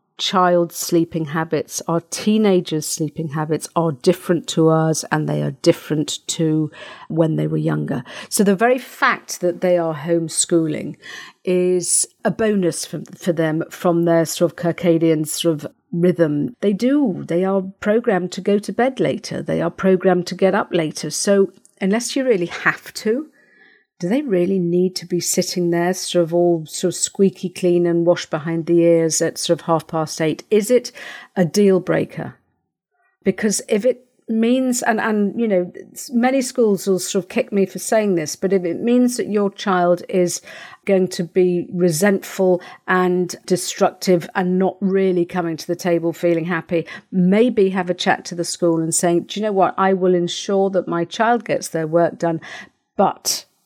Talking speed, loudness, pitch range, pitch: 180 wpm, -19 LUFS, 170-200 Hz, 180 Hz